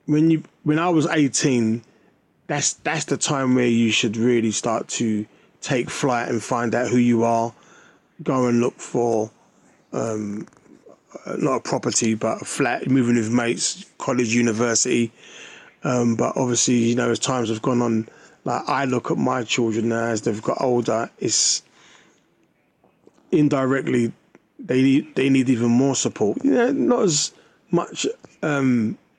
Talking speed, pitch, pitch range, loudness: 155 wpm, 120 Hz, 115-135 Hz, -21 LUFS